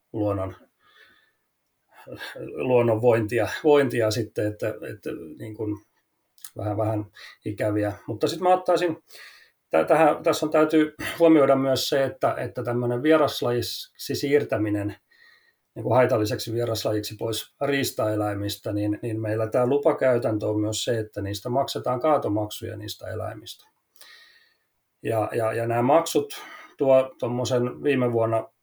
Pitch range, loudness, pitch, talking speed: 110-140 Hz, -24 LUFS, 120 Hz, 120 wpm